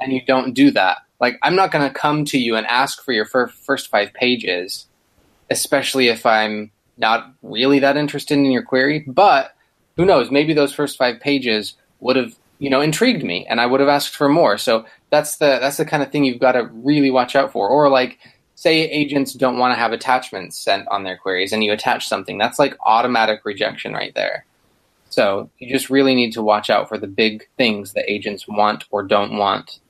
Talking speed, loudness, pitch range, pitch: 215 wpm, -17 LUFS, 110-140 Hz, 130 Hz